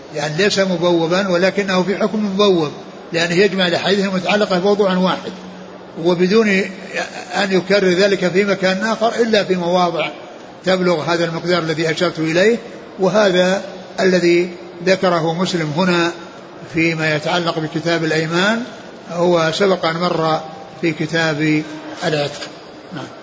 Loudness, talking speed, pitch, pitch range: -17 LUFS, 120 wpm, 180 Hz, 165-195 Hz